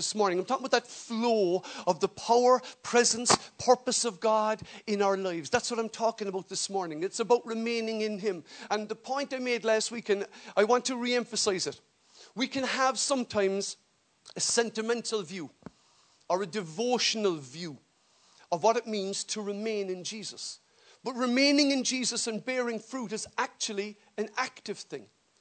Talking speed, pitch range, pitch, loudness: 175 wpm, 200-245 Hz, 220 Hz, -29 LUFS